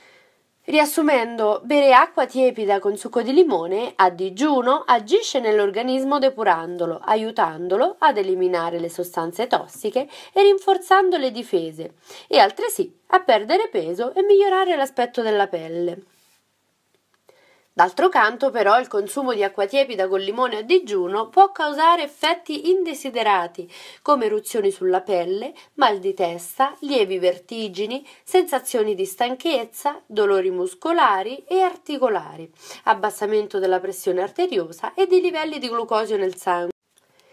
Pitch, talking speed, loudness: 250 Hz, 120 wpm, -20 LUFS